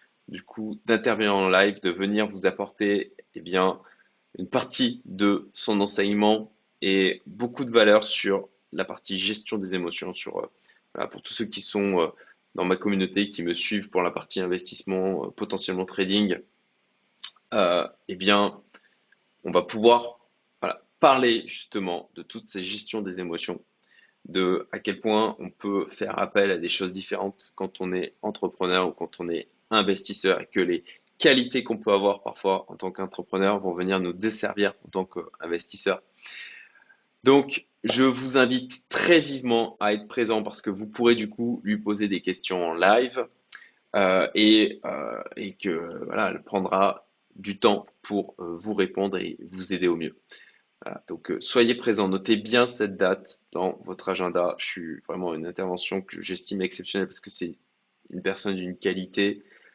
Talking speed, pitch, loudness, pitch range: 170 wpm, 100 Hz, -25 LUFS, 95-110 Hz